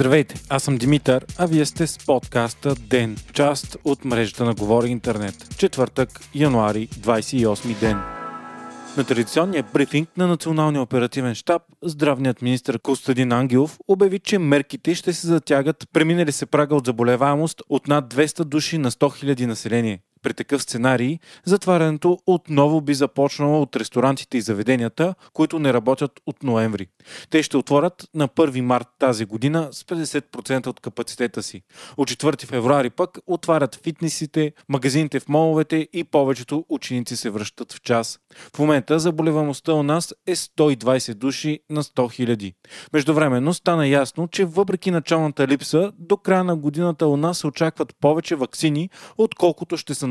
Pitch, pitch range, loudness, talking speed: 145 Hz, 125-160 Hz, -21 LUFS, 150 wpm